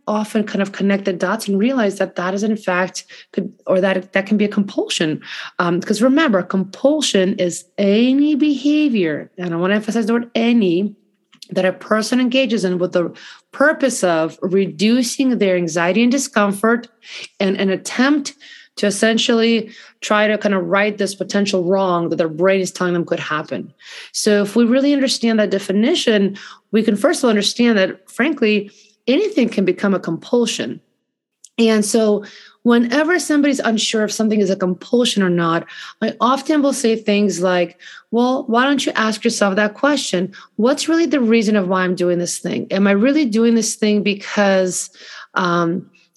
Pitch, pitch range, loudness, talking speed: 210 Hz, 190-235 Hz, -17 LUFS, 175 wpm